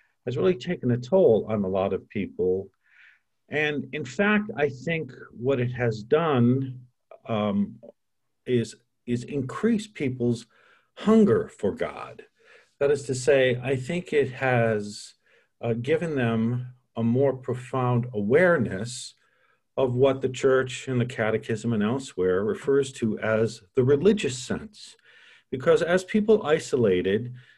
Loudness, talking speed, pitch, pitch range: -25 LUFS, 135 wpm, 130 Hz, 120-150 Hz